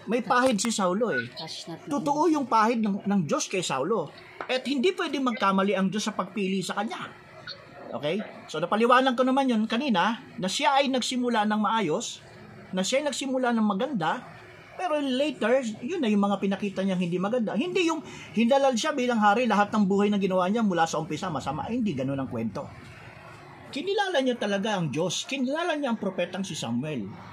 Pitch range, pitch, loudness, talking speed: 185-255 Hz, 215 Hz, -26 LUFS, 180 wpm